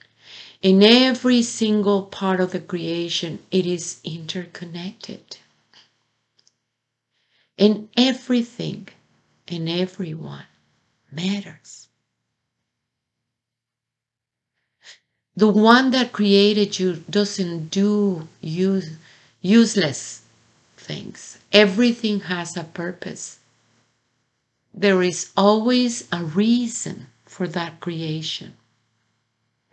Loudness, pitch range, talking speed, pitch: -20 LUFS, 125-205 Hz, 75 wpm, 175 Hz